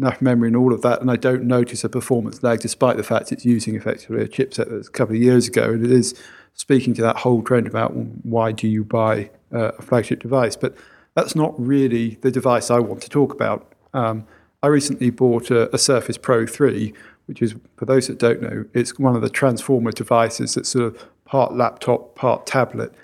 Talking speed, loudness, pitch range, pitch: 220 wpm, -19 LUFS, 115-130 Hz, 120 Hz